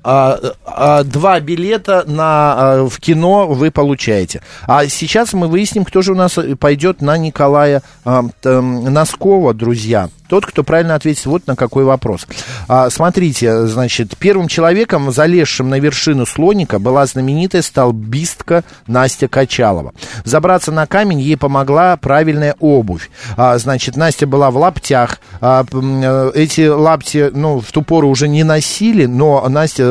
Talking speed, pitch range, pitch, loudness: 145 wpm, 130-165 Hz, 145 Hz, -12 LUFS